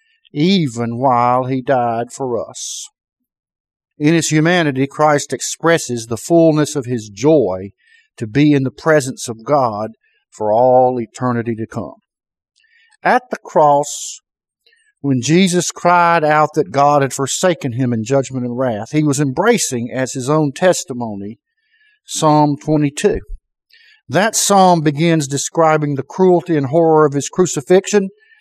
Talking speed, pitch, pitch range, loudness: 135 wpm, 150 Hz, 130-175 Hz, -15 LUFS